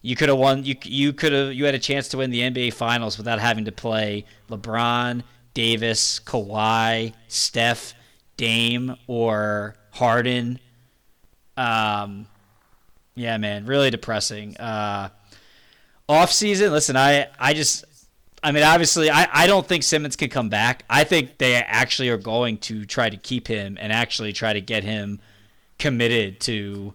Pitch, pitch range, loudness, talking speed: 115 Hz, 110-130 Hz, -21 LUFS, 155 wpm